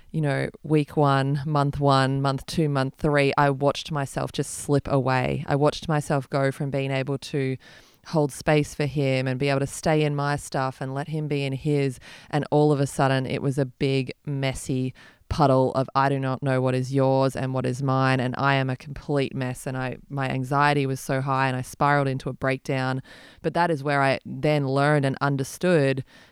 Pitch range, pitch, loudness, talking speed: 135-145 Hz, 140 Hz, -24 LUFS, 210 wpm